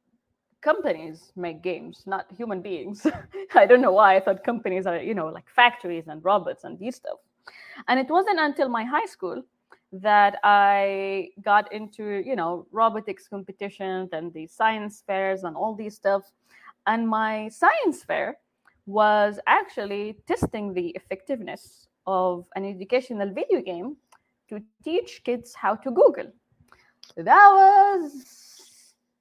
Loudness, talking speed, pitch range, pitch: -22 LUFS, 140 wpm, 190-250 Hz, 210 Hz